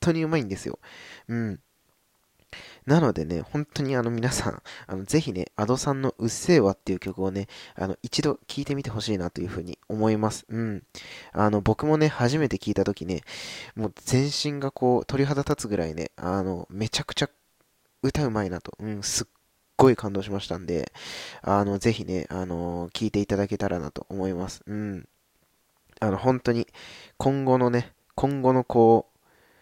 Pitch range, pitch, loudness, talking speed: 95-130 Hz, 110 Hz, -26 LUFS, 340 characters per minute